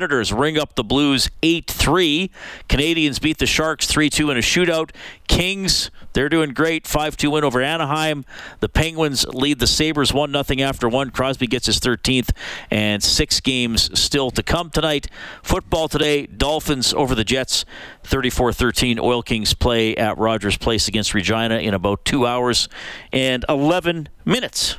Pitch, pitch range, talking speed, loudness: 130 Hz, 115-150 Hz, 150 wpm, -18 LUFS